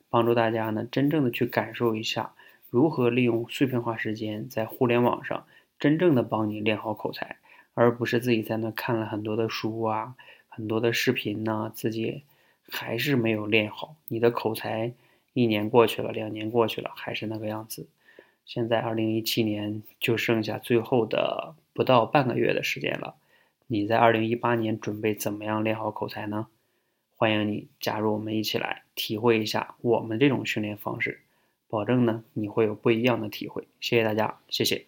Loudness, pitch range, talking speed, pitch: -26 LUFS, 110-120 Hz, 280 characters per minute, 110 Hz